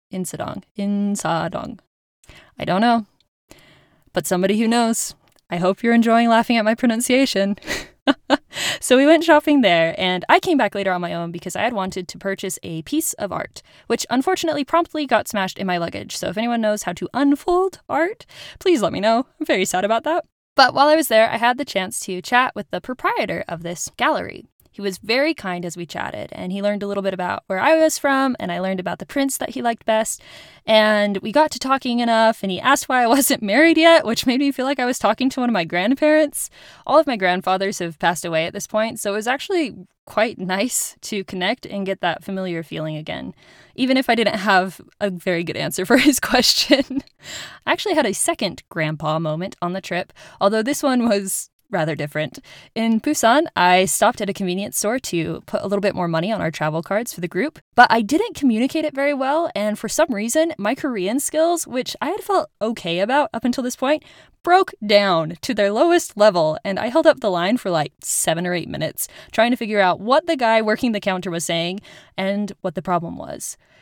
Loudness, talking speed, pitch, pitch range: -19 LUFS, 220 wpm, 220 Hz, 185-275 Hz